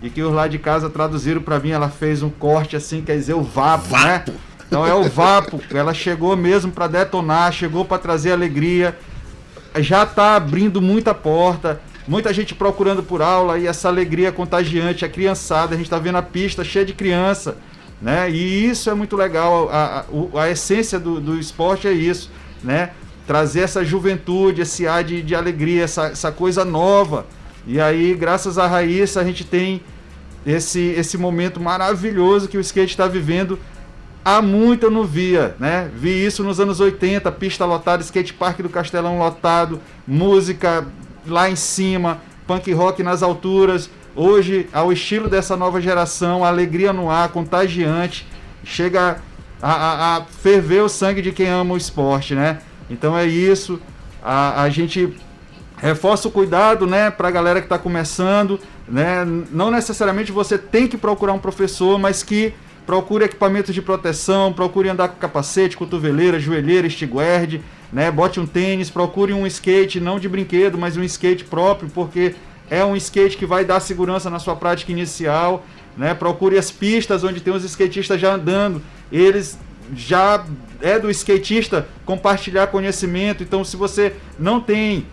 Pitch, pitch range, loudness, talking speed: 180 Hz, 165-195 Hz, -18 LUFS, 165 wpm